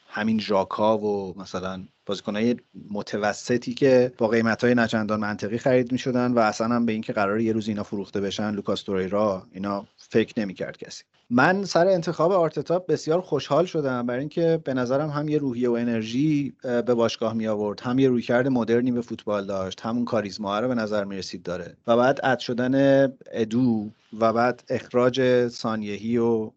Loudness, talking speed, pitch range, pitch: -24 LUFS, 165 wpm, 105-130 Hz, 120 Hz